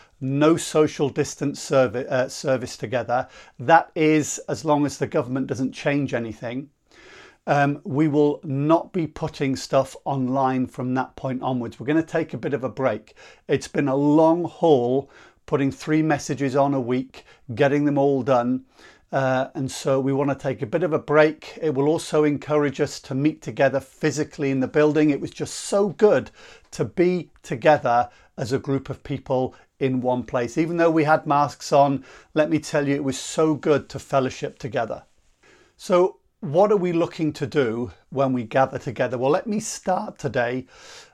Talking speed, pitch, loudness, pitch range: 185 wpm, 140 Hz, -23 LUFS, 130-155 Hz